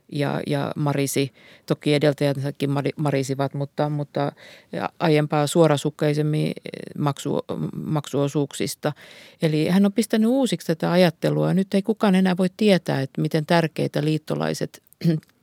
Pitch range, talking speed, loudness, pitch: 140-180 Hz, 115 wpm, -23 LUFS, 150 Hz